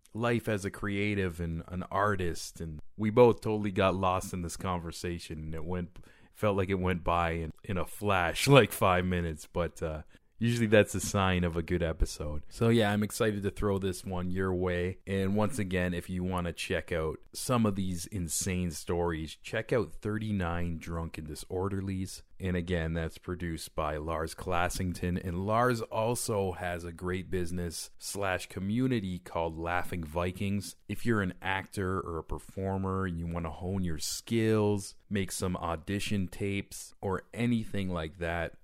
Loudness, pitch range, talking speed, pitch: -32 LUFS, 85-100 Hz, 175 wpm, 90 Hz